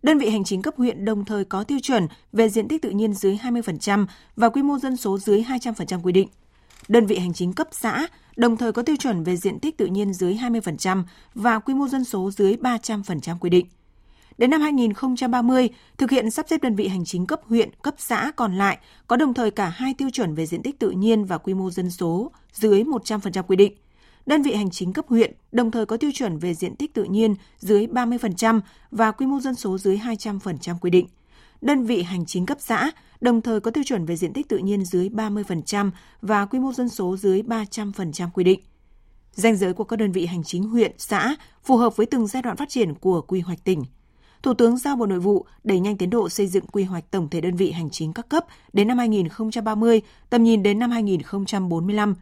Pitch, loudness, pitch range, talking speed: 215 Hz, -22 LUFS, 190-245 Hz, 230 wpm